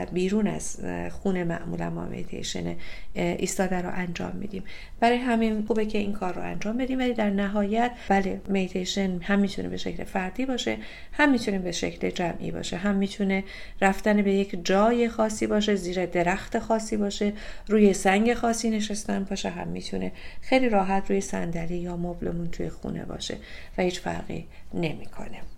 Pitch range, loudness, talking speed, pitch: 175-215 Hz, -27 LUFS, 160 wpm, 195 Hz